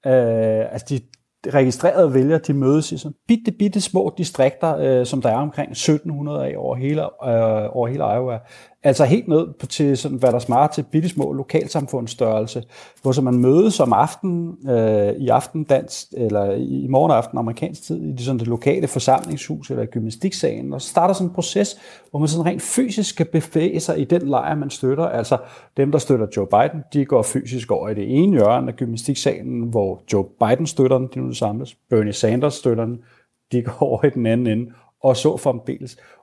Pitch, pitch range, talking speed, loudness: 135 Hz, 120-155 Hz, 200 wpm, -19 LUFS